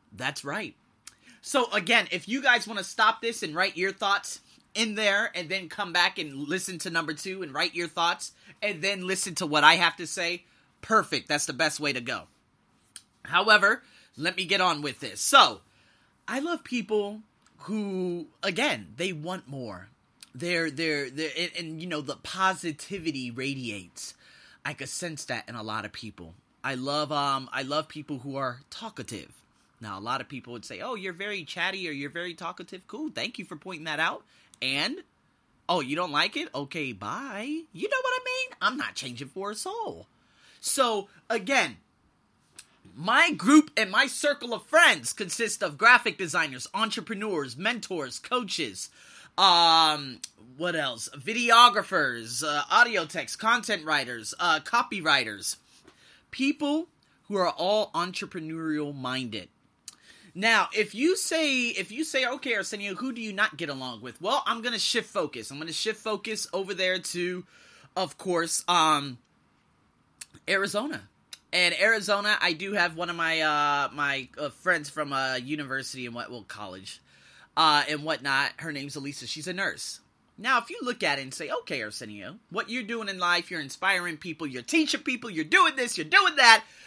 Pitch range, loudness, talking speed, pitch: 145-220 Hz, -26 LUFS, 175 wpm, 175 Hz